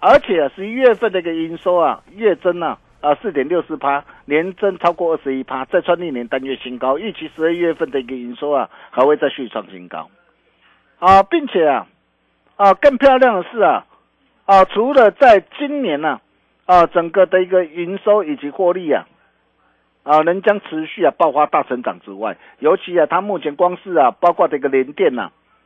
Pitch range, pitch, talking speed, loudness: 140-190 Hz, 170 Hz, 290 characters per minute, -16 LUFS